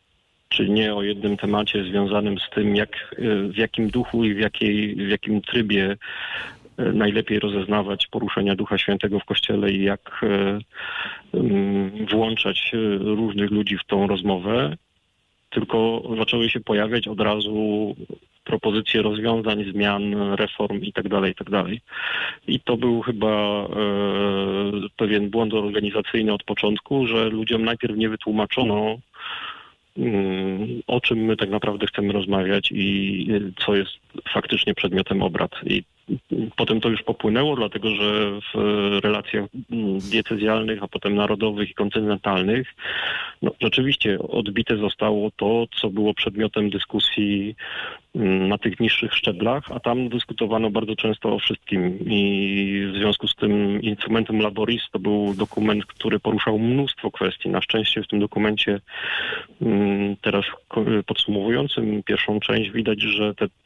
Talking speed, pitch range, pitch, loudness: 125 wpm, 100-110 Hz, 105 Hz, -22 LUFS